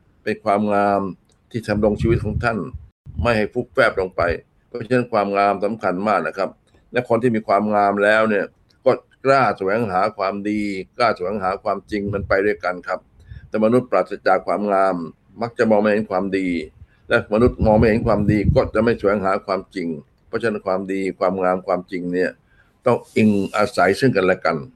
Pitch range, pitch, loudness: 95-110 Hz, 100 Hz, -20 LUFS